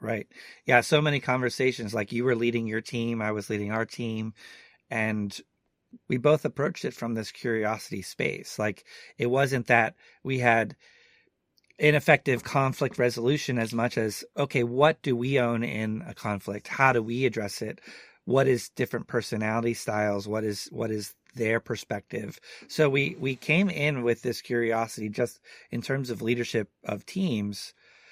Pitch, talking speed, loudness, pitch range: 120 Hz, 160 wpm, -27 LUFS, 110-135 Hz